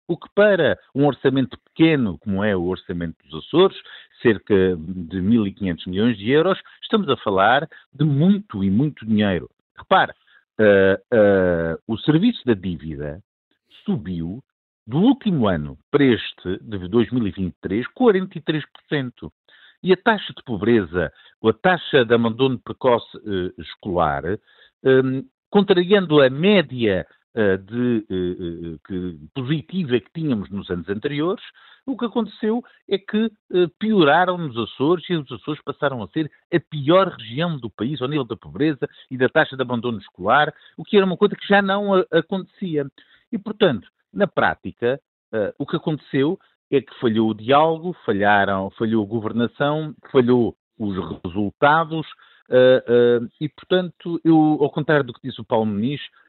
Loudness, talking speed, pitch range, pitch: -20 LUFS, 150 wpm, 105-170 Hz, 130 Hz